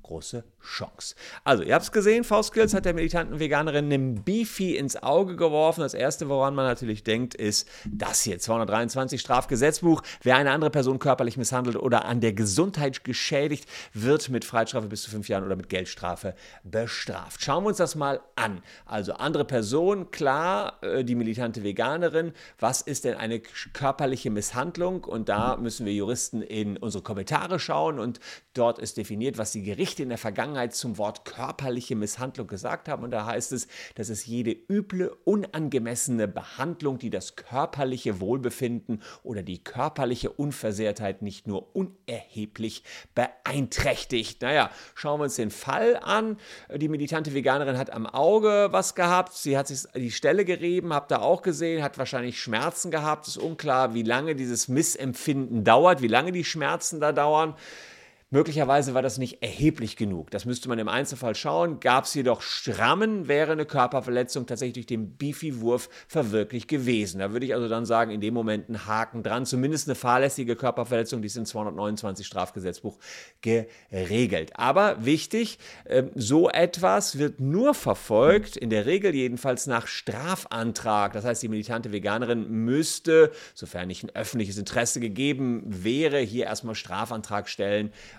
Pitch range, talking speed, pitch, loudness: 110-150 Hz, 160 wpm, 125 Hz, -26 LUFS